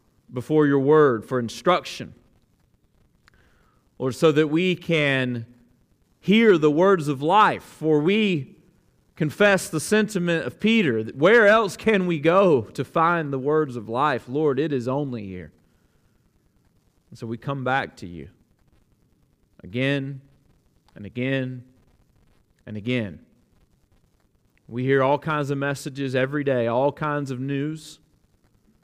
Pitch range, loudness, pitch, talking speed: 120-155 Hz, -22 LUFS, 140 Hz, 130 wpm